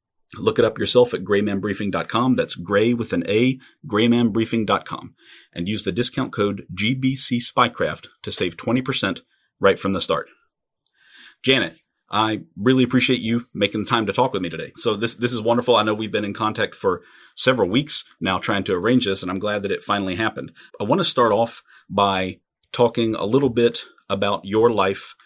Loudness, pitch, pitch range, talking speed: -20 LUFS, 110 Hz, 100-120 Hz, 185 wpm